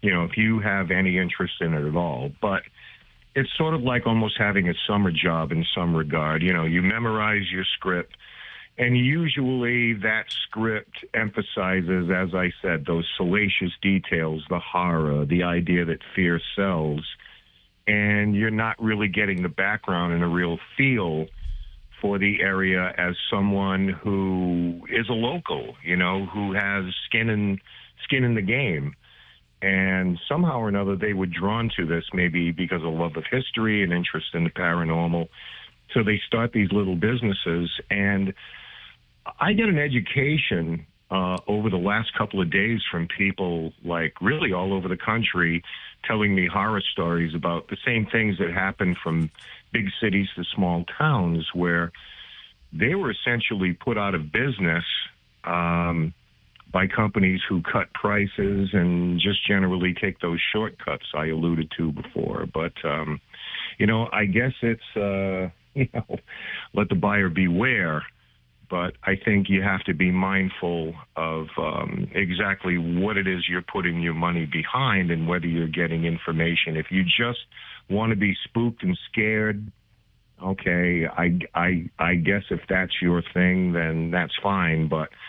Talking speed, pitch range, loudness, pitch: 160 wpm, 85-105 Hz, -24 LUFS, 95 Hz